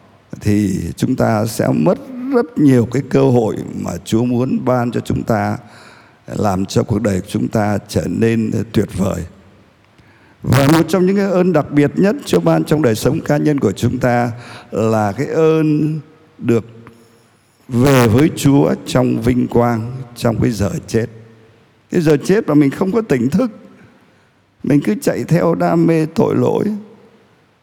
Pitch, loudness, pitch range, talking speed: 125 Hz, -15 LUFS, 110-155 Hz, 170 wpm